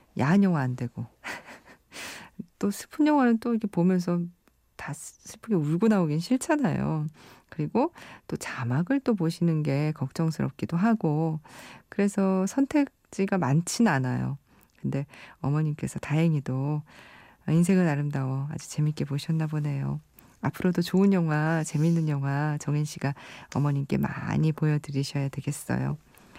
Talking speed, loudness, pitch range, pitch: 290 characters per minute, -27 LUFS, 140-185 Hz, 155 Hz